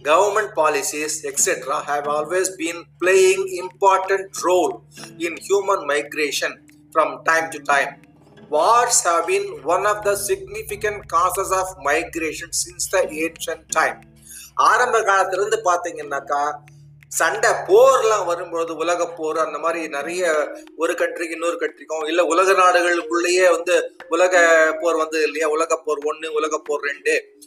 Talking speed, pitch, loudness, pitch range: 105 wpm, 170 Hz, -19 LUFS, 155-190 Hz